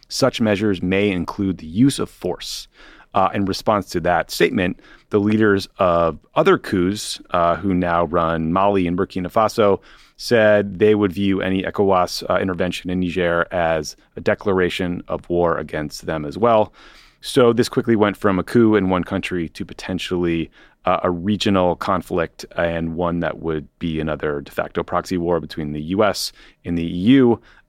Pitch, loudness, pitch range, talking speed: 90 Hz, -19 LUFS, 85-100 Hz, 170 wpm